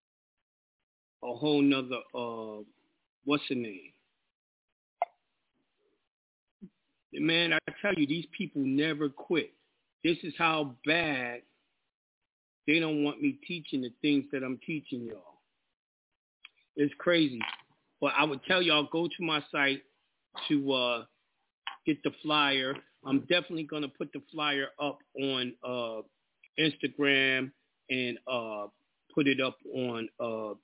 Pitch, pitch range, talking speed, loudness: 140 Hz, 130-155 Hz, 125 wpm, -30 LUFS